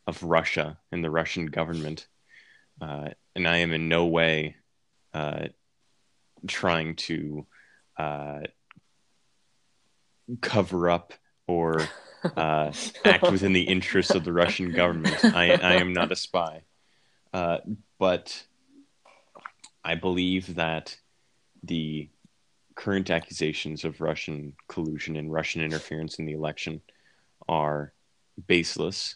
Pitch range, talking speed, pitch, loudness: 75-90 Hz, 110 wpm, 80 Hz, -26 LUFS